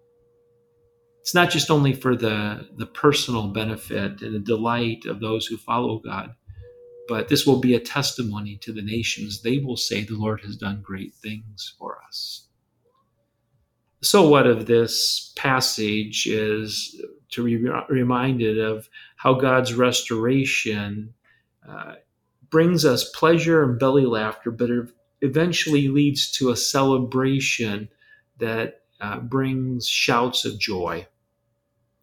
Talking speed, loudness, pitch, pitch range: 130 wpm, -22 LUFS, 120 Hz, 110-140 Hz